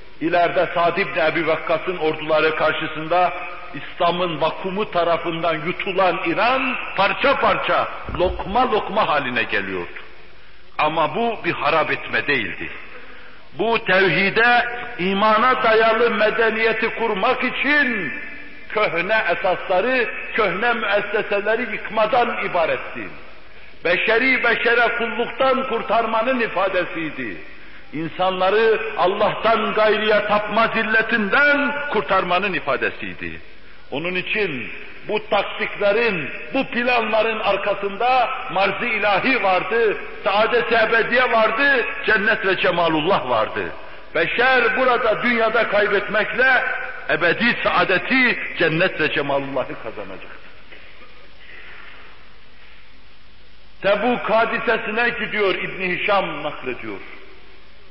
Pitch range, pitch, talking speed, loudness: 180-230 Hz, 210 Hz, 85 wpm, -19 LUFS